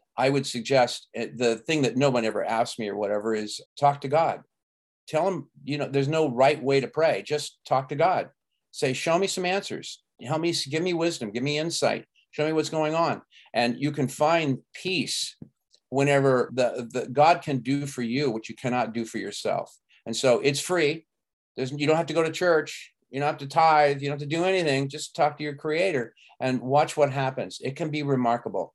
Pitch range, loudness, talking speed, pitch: 130-155 Hz, -25 LUFS, 215 wpm, 140 Hz